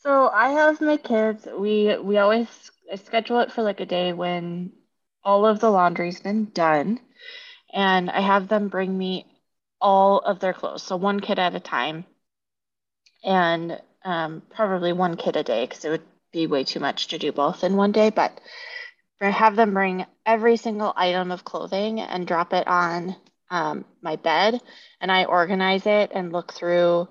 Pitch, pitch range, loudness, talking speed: 190 Hz, 175-220 Hz, -22 LUFS, 180 wpm